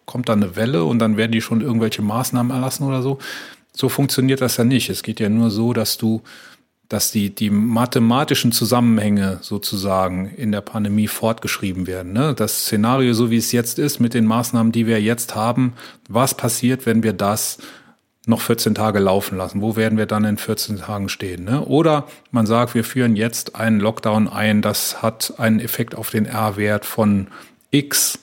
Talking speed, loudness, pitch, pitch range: 190 wpm, -19 LUFS, 115 Hz, 105-120 Hz